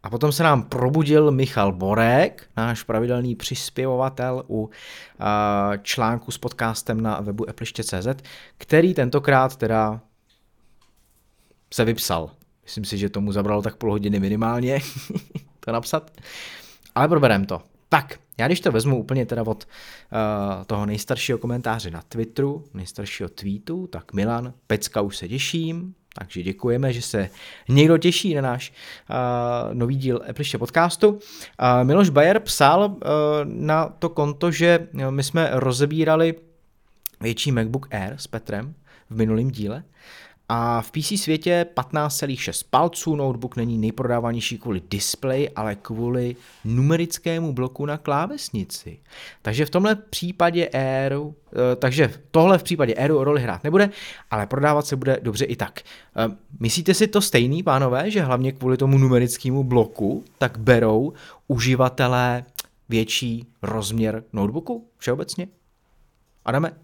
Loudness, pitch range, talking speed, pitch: -22 LUFS, 110-150 Hz, 130 wpm, 125 Hz